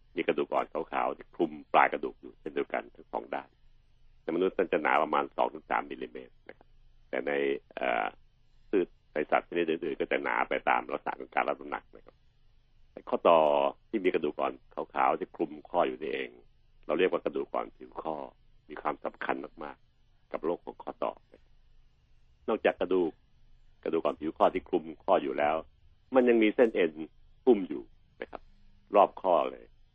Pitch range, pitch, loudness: 65-110 Hz, 75 Hz, -30 LUFS